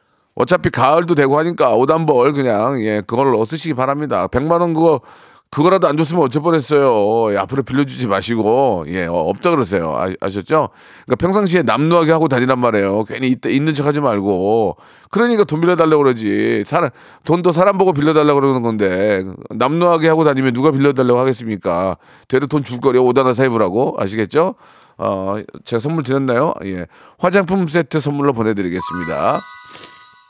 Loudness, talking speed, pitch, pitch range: -15 LUFS, 380 characters per minute, 135 Hz, 120-160 Hz